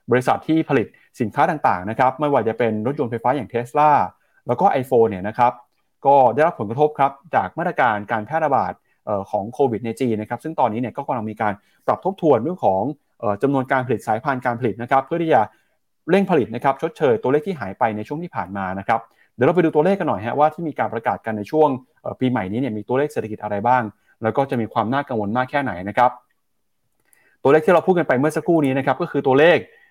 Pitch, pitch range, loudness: 130 Hz, 110-150 Hz, -20 LUFS